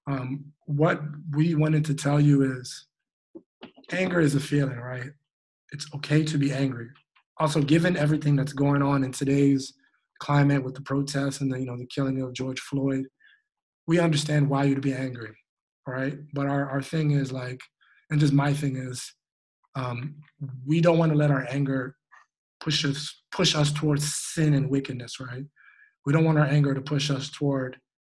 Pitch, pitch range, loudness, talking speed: 140 Hz, 135-150 Hz, -25 LUFS, 175 wpm